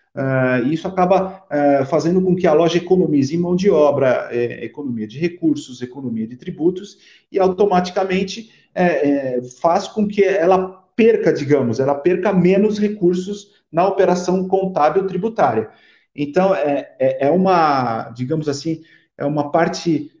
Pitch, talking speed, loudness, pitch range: 175 Hz, 145 wpm, -18 LUFS, 145-190 Hz